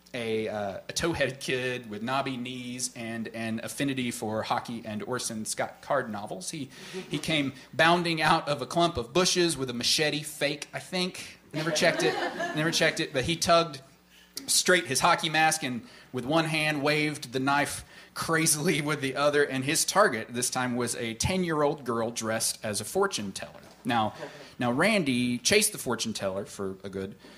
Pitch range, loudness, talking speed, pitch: 115-160 Hz, -27 LUFS, 180 wpm, 135 Hz